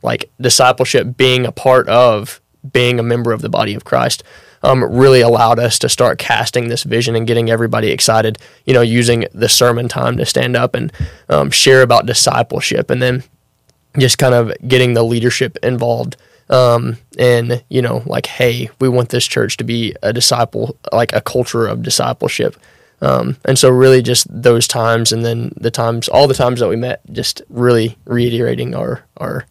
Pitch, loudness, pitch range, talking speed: 120 Hz, -13 LUFS, 115-125 Hz, 185 wpm